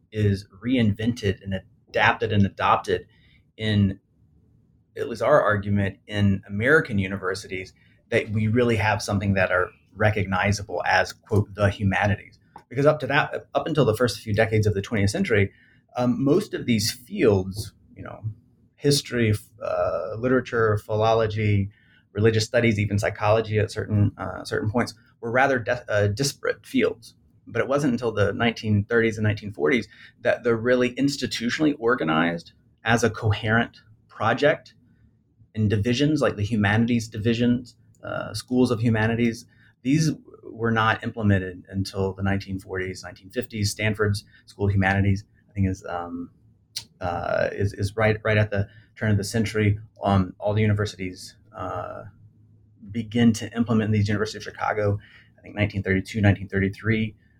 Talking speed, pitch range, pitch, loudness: 140 wpm, 100-115 Hz, 110 Hz, -24 LUFS